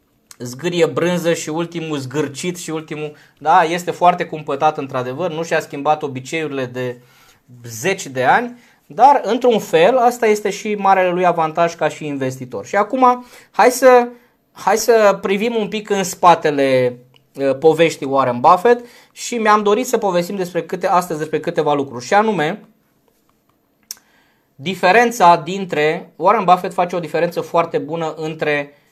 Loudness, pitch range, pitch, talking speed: -16 LUFS, 150-200 Hz, 170 Hz, 140 wpm